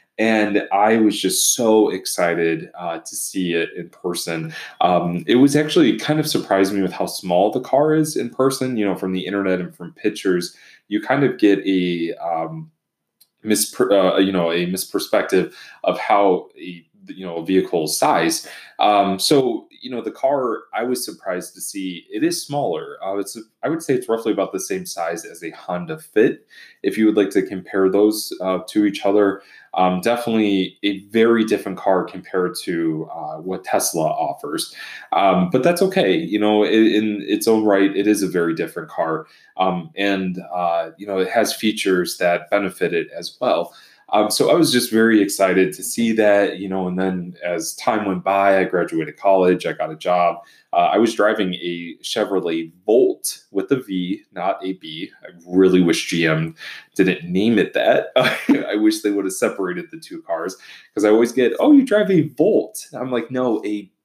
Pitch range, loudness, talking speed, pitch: 95-120 Hz, -19 LUFS, 195 wpm, 100 Hz